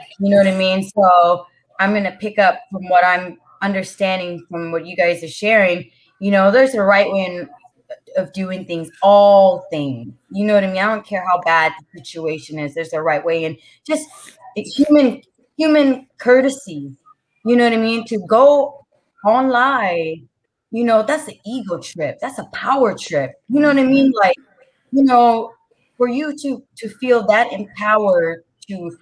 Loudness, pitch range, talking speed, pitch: -16 LUFS, 175-255 Hz, 185 wpm, 200 Hz